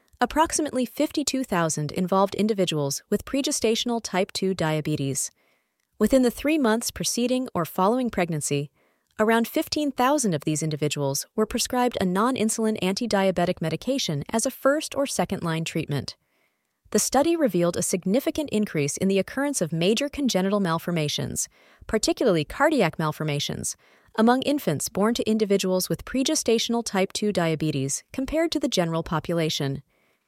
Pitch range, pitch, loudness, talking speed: 165-255 Hz, 205 Hz, -24 LUFS, 135 wpm